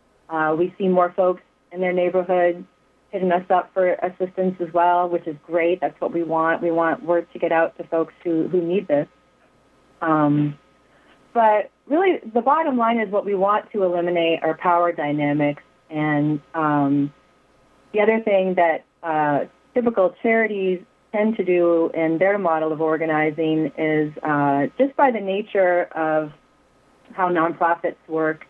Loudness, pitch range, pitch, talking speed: -21 LUFS, 160-190 Hz, 175 Hz, 160 wpm